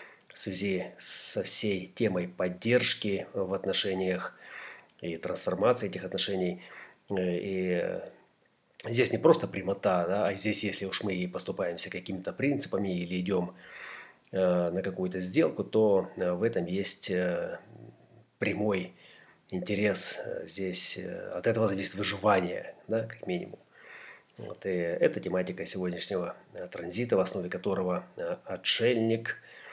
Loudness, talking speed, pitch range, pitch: -29 LUFS, 115 wpm, 90-100 Hz, 95 Hz